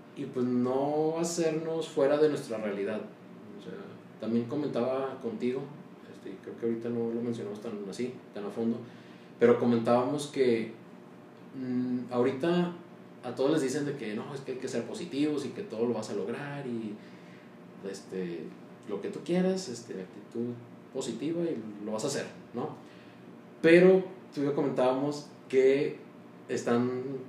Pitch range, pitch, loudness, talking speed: 105-140 Hz, 120 Hz, -31 LUFS, 155 wpm